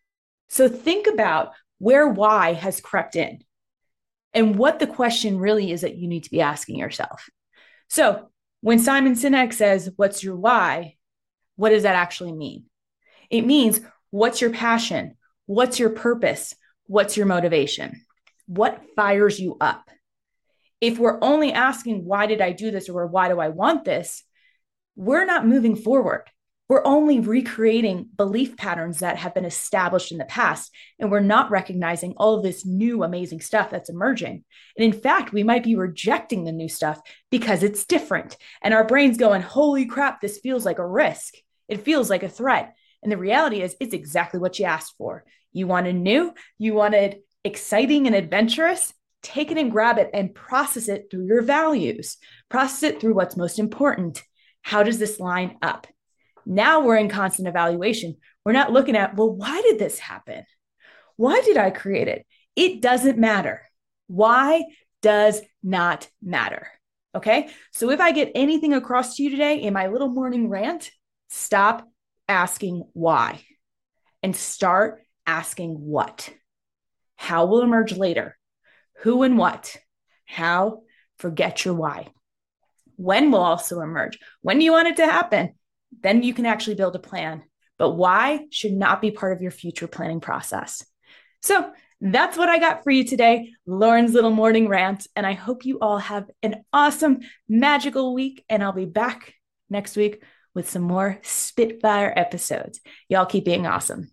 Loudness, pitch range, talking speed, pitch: -21 LUFS, 190-260 Hz, 165 wpm, 215 Hz